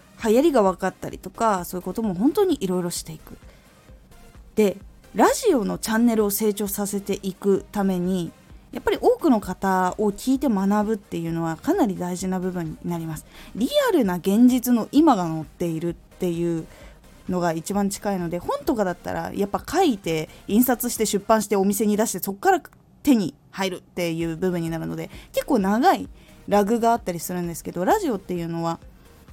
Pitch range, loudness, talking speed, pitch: 175-230 Hz, -23 LUFS, 370 characters per minute, 195 Hz